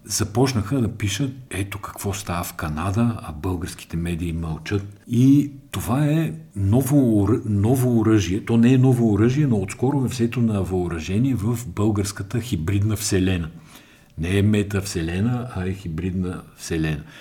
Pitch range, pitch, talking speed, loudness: 95-120 Hz, 105 Hz, 135 wpm, -22 LUFS